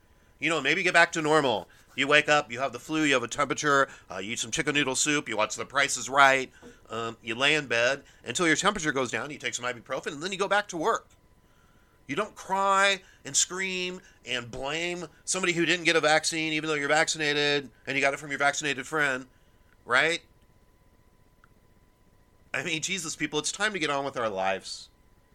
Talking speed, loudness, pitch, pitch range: 210 wpm, -26 LUFS, 145 Hz, 130-165 Hz